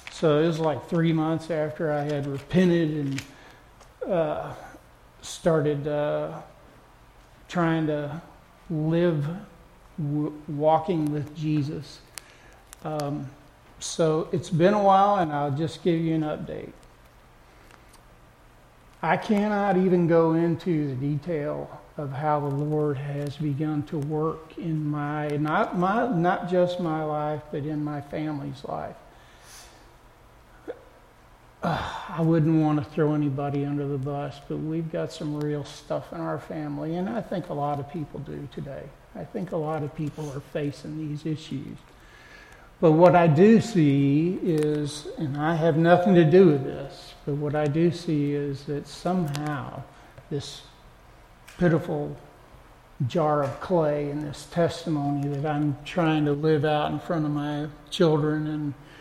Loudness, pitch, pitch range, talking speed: -25 LUFS, 150 Hz, 145-165 Hz, 145 wpm